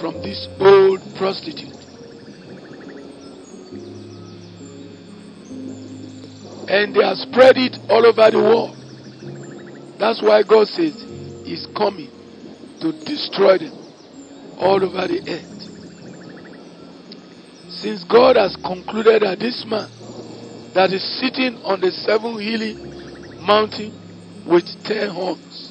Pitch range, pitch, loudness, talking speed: 165-230 Hz, 200 Hz, -17 LUFS, 100 wpm